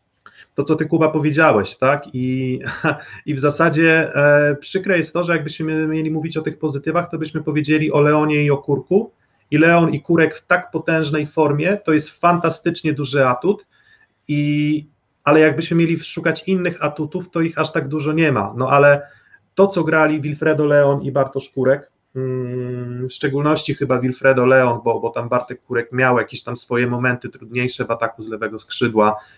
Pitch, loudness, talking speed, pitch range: 150 Hz, -18 LUFS, 175 wpm, 130-160 Hz